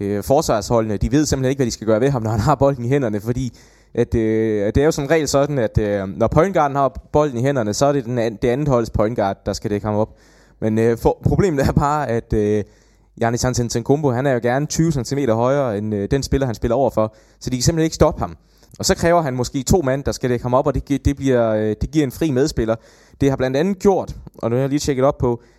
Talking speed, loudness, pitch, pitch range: 270 wpm, -19 LUFS, 125 Hz, 110-140 Hz